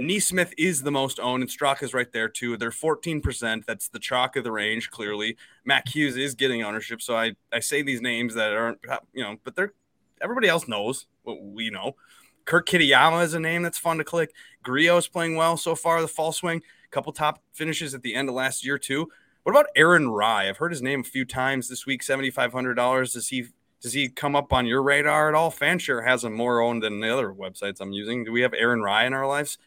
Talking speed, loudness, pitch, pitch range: 235 wpm, -24 LUFS, 135 Hz, 120-160 Hz